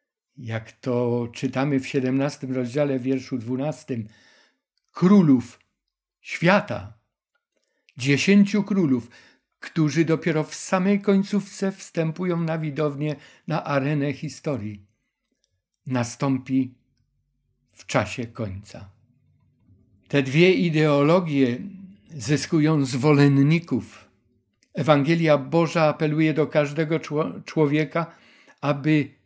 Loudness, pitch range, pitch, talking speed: -23 LUFS, 125-160 Hz, 140 Hz, 80 wpm